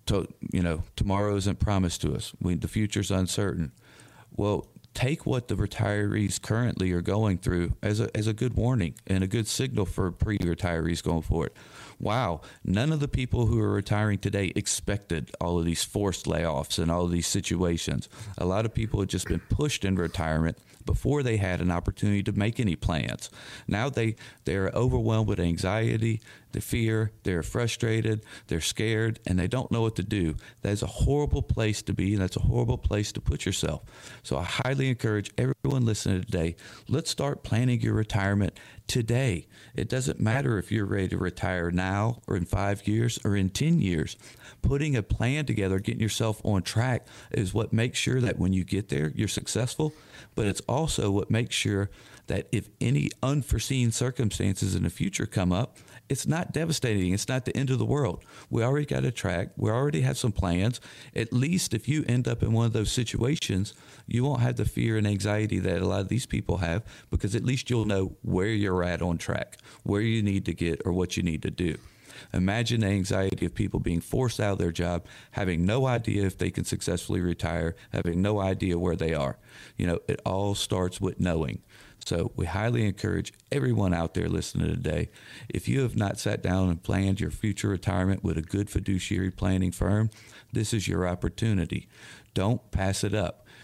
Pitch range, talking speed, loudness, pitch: 95-115 Hz, 195 wpm, -28 LUFS, 105 Hz